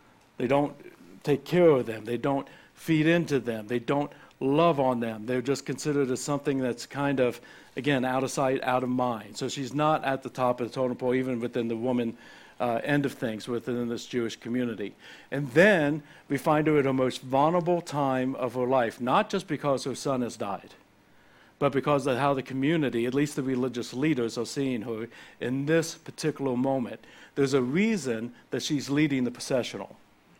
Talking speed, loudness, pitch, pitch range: 195 wpm, -28 LUFS, 135 Hz, 125-145 Hz